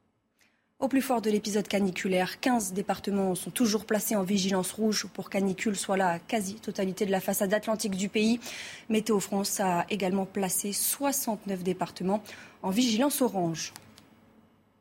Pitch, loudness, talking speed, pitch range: 205 Hz, -29 LUFS, 140 wpm, 190-220 Hz